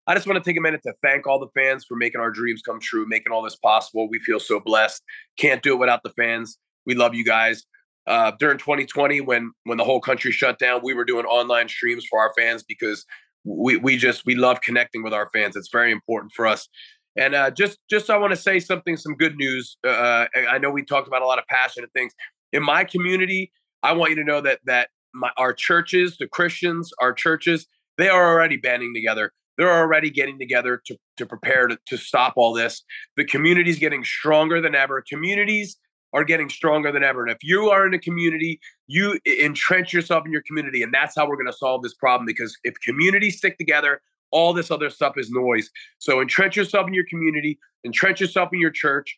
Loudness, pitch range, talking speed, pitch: -20 LUFS, 120-175 Hz, 225 wpm, 145 Hz